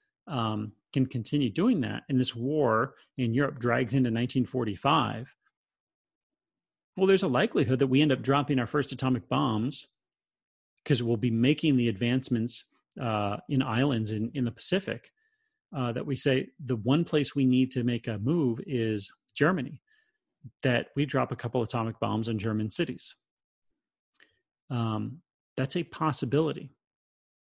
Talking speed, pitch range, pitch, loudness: 150 wpm, 115-145 Hz, 130 Hz, -28 LUFS